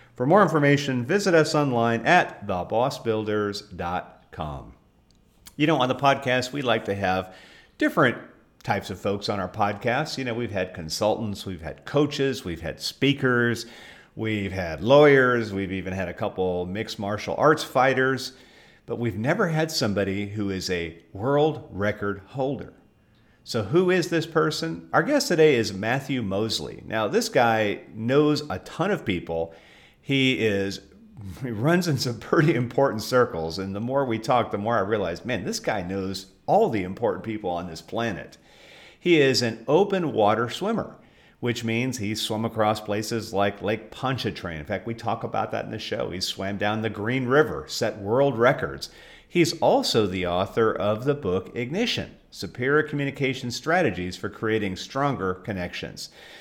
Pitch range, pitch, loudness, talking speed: 100-140 Hz, 115 Hz, -24 LUFS, 165 wpm